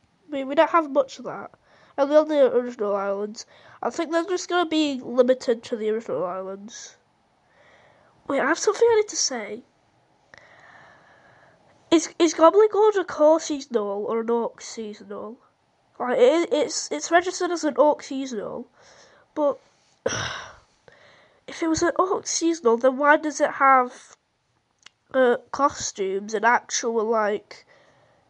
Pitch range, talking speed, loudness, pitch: 235-330 Hz, 150 wpm, -22 LUFS, 280 Hz